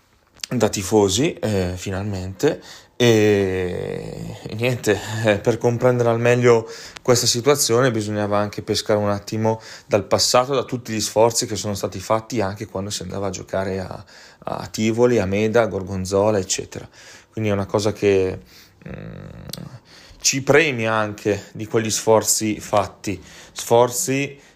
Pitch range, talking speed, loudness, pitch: 100-120 Hz, 140 wpm, -20 LUFS, 110 Hz